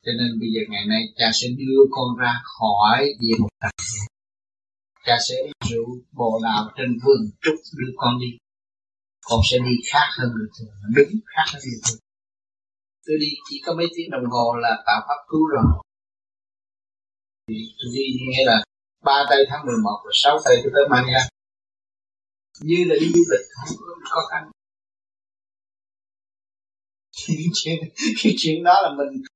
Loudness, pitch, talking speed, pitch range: -20 LUFS, 120 Hz, 160 wpm, 100-145 Hz